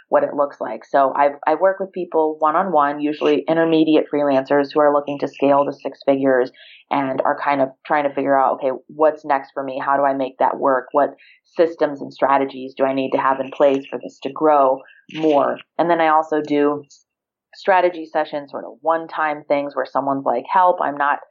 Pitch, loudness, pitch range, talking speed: 145 Hz, -19 LUFS, 135-155 Hz, 215 wpm